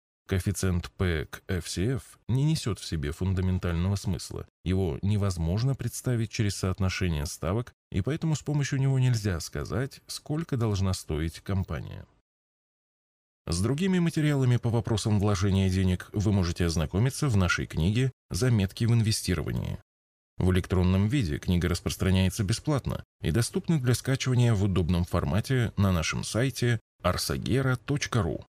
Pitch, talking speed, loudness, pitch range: 100 Hz, 125 wpm, -28 LUFS, 90-125 Hz